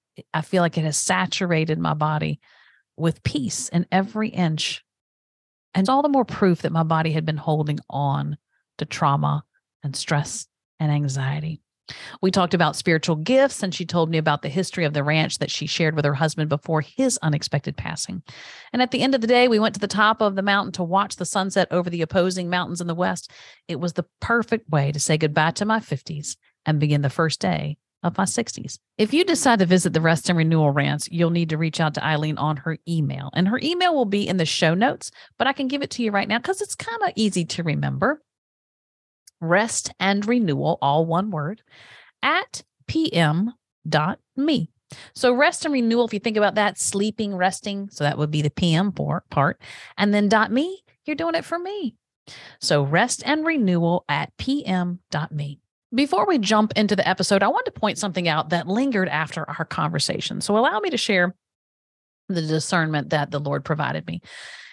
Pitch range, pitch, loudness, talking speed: 155-215 Hz, 175 Hz, -22 LUFS, 200 wpm